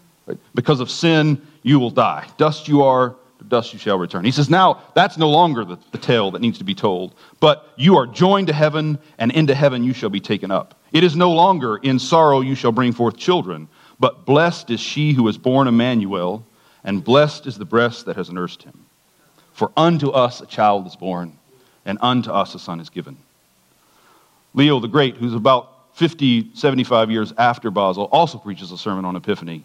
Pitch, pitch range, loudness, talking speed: 130 Hz, 110-150 Hz, -17 LUFS, 200 wpm